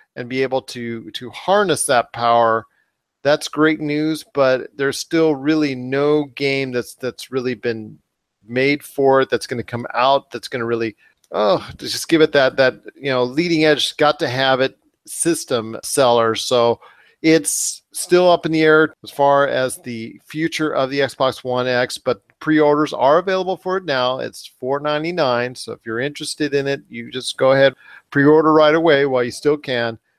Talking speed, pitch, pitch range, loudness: 180 wpm, 135 Hz, 125-155 Hz, -18 LUFS